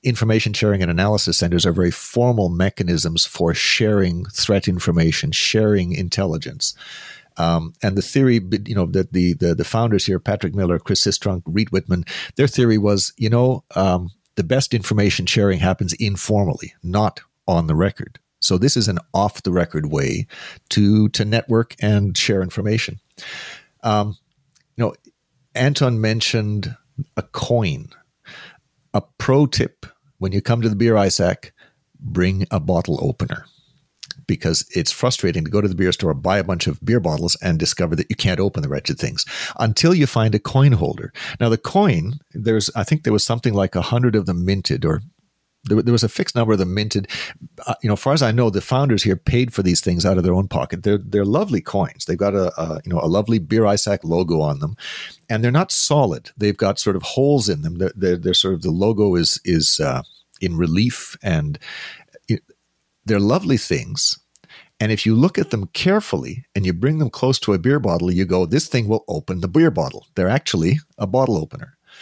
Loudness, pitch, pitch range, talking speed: -19 LUFS, 105 Hz, 95-120 Hz, 195 wpm